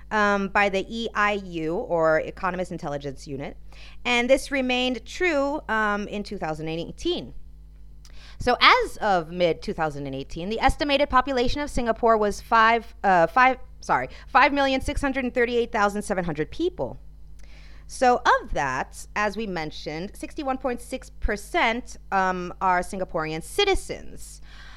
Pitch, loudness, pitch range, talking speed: 210 Hz, -24 LUFS, 180-260 Hz, 100 wpm